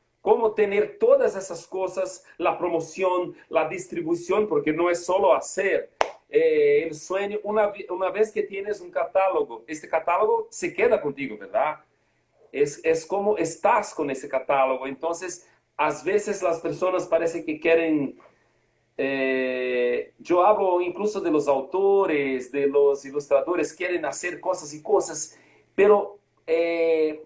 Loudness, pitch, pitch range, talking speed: -24 LUFS, 180 Hz, 155-210 Hz, 135 wpm